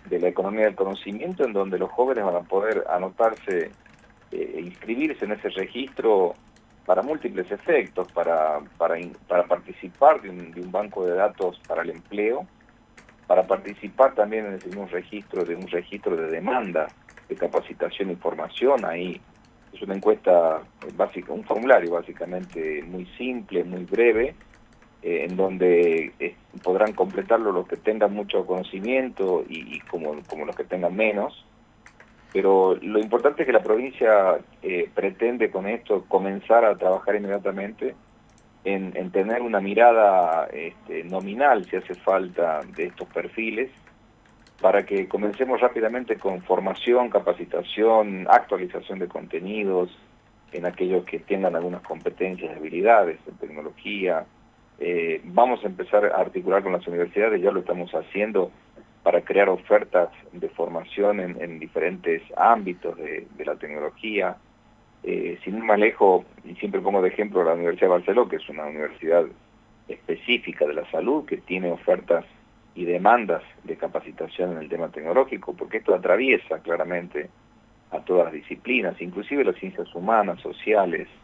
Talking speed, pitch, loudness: 145 wpm, 110 Hz, -24 LUFS